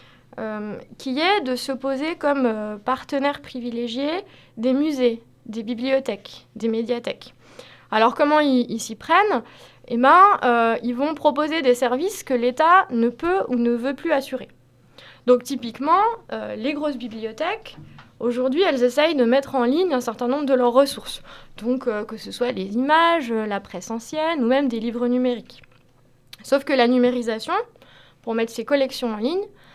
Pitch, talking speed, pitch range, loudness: 250 Hz, 165 wpm, 230-290 Hz, -21 LUFS